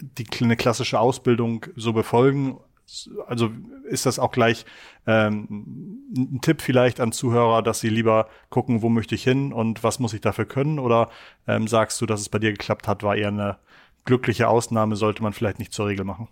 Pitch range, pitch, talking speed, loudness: 110-125 Hz, 115 Hz, 195 wpm, -22 LUFS